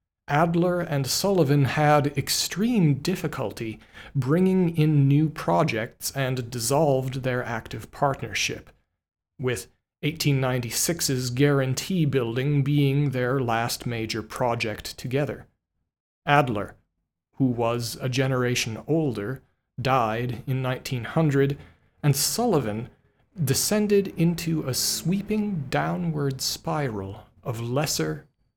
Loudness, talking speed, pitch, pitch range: -25 LUFS, 90 wpm, 135 Hz, 120-155 Hz